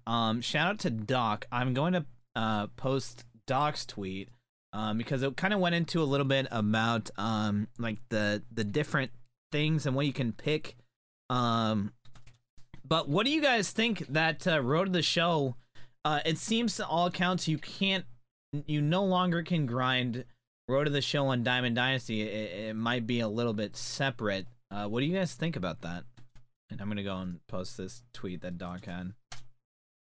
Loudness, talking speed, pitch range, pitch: -31 LUFS, 190 wpm, 110-150 Hz, 125 Hz